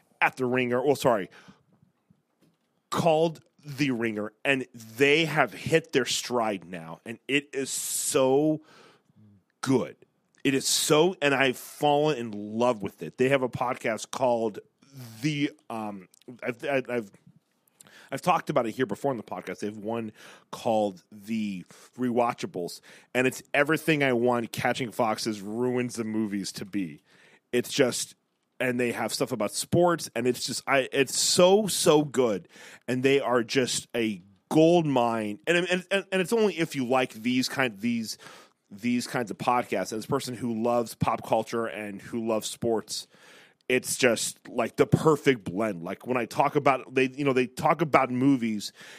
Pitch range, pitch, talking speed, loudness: 115-145 Hz, 125 Hz, 165 wpm, -26 LUFS